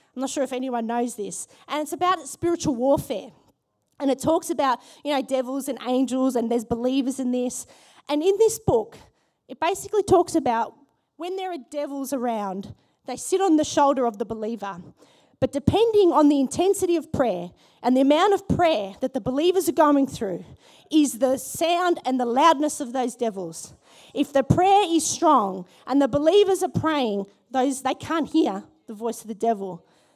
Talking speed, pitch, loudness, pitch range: 185 wpm, 275 Hz, -23 LUFS, 245-330 Hz